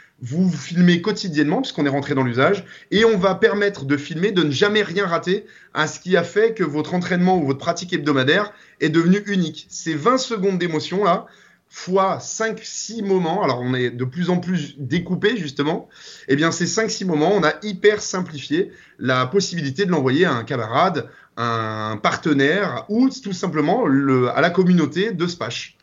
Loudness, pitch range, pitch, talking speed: -20 LUFS, 150-200 Hz, 175 Hz, 185 wpm